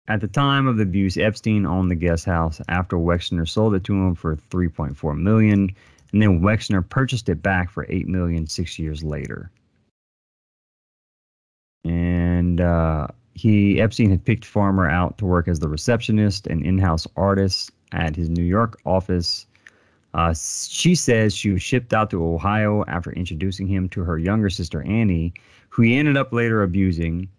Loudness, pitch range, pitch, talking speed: -21 LUFS, 85-105 Hz, 95 Hz, 165 wpm